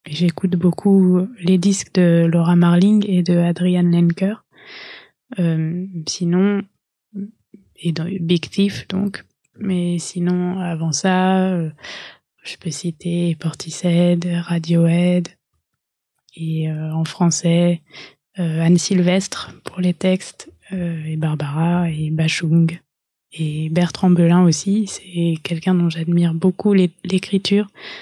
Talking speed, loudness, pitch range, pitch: 110 wpm, -18 LUFS, 165-185 Hz, 175 Hz